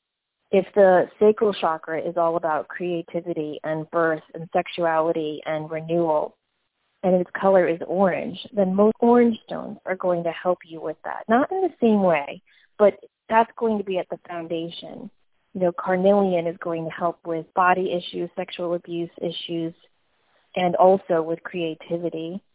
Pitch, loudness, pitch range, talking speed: 175 Hz, -23 LUFS, 165-195 Hz, 160 wpm